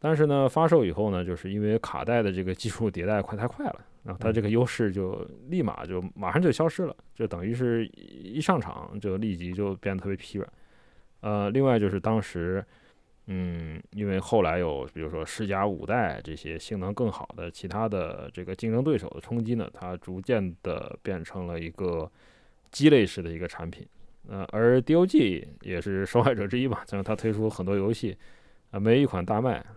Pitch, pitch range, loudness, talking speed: 100 Hz, 90-115 Hz, -28 LUFS, 290 characters per minute